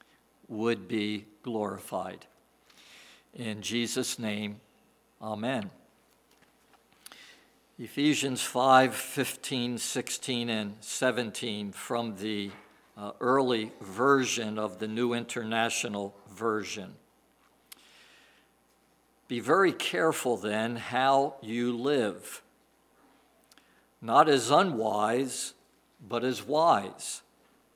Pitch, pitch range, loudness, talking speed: 115 Hz, 105-125 Hz, -29 LUFS, 80 wpm